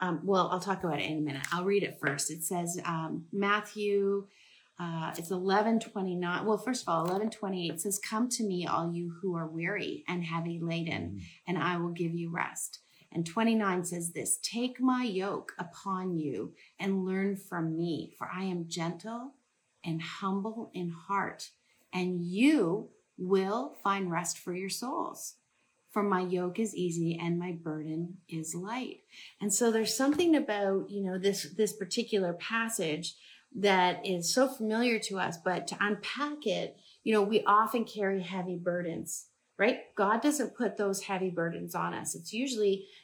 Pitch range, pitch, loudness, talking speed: 170-215 Hz, 190 Hz, -32 LUFS, 170 wpm